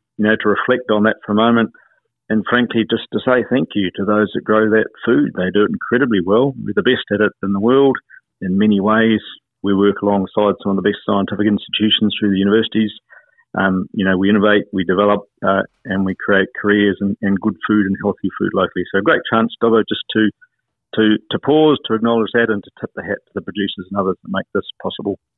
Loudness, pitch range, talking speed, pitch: -17 LUFS, 100-110 Hz, 225 wpm, 105 Hz